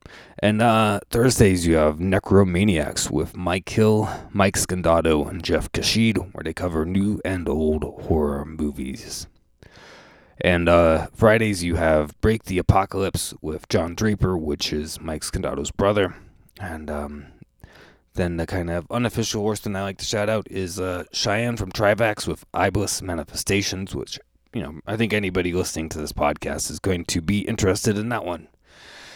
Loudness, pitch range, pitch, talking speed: -22 LUFS, 80-105 Hz, 90 Hz, 160 wpm